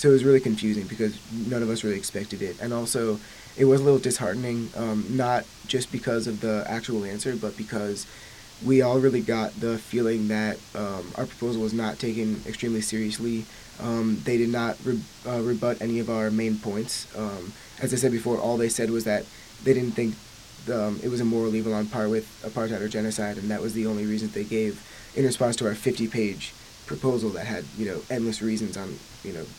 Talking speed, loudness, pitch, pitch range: 215 wpm, -26 LUFS, 115 Hz, 110-120 Hz